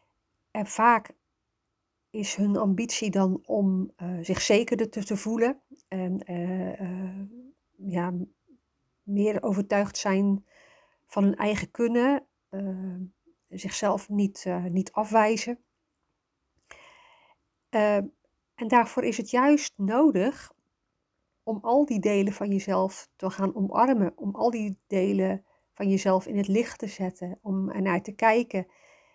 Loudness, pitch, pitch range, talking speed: -27 LUFS, 205 Hz, 190-235 Hz, 130 wpm